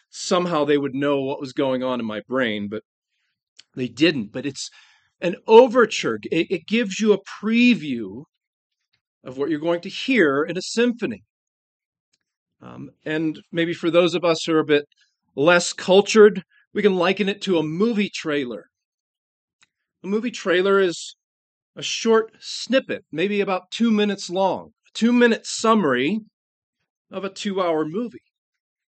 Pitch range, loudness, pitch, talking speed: 155-220 Hz, -21 LUFS, 190 Hz, 155 wpm